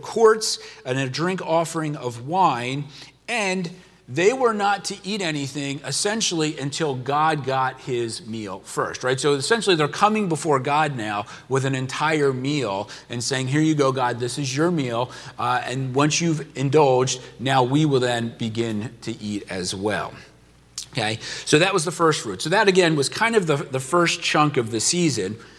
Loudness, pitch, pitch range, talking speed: -22 LUFS, 140 Hz, 125-165 Hz, 180 wpm